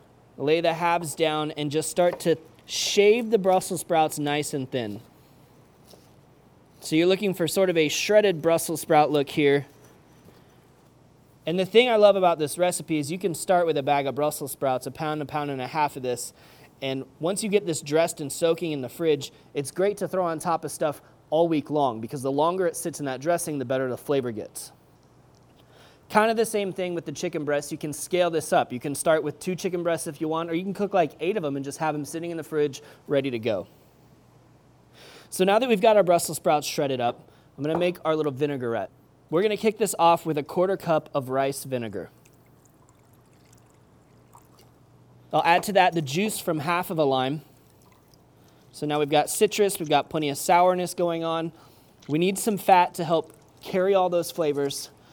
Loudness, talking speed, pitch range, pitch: -25 LUFS, 210 wpm, 145-180 Hz, 160 Hz